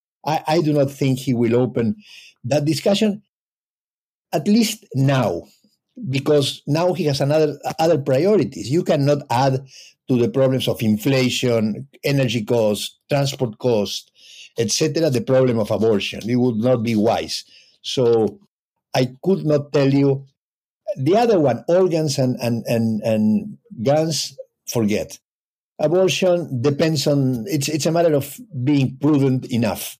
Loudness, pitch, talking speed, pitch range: -19 LUFS, 135 Hz, 140 wpm, 125-155 Hz